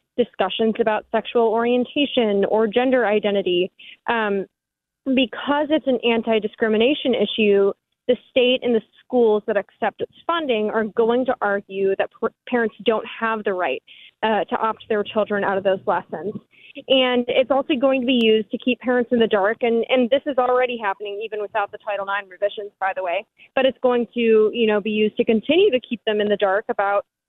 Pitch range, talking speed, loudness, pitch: 205-250 Hz, 190 wpm, -21 LUFS, 225 Hz